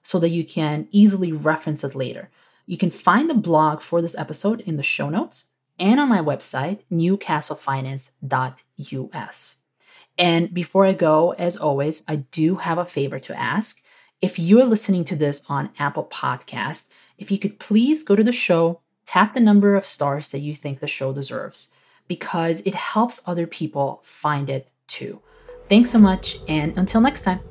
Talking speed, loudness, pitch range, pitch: 175 wpm, -21 LUFS, 150-195 Hz, 170 Hz